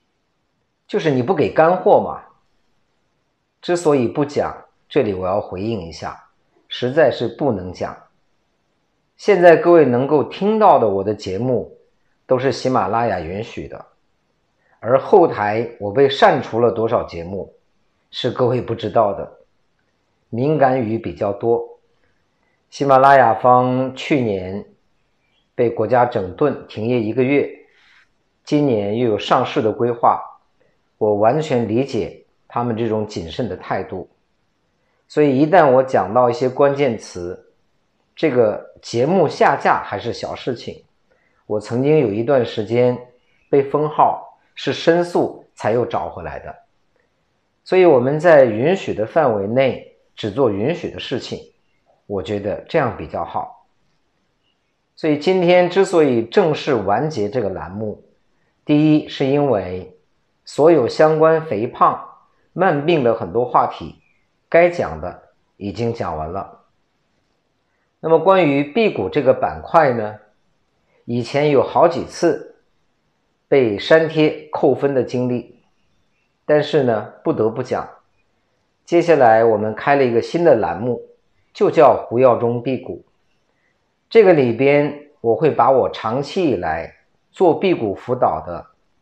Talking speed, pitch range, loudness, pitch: 200 characters per minute, 115-150 Hz, -17 LUFS, 125 Hz